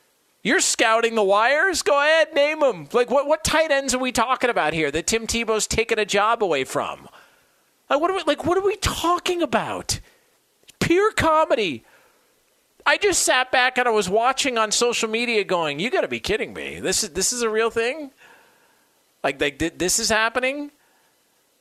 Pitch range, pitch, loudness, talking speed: 225-315 Hz, 255 Hz, -20 LUFS, 190 wpm